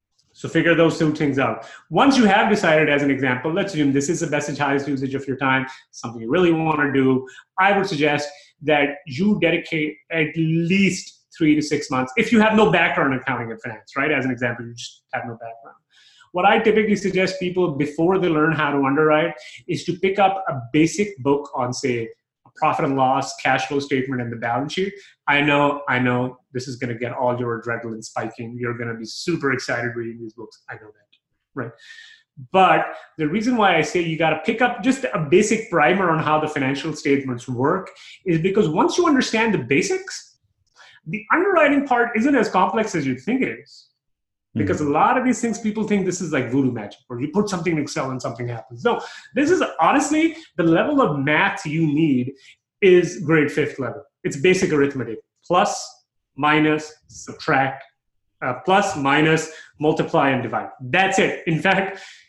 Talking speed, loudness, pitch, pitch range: 200 wpm, -20 LUFS, 155 Hz, 130-190 Hz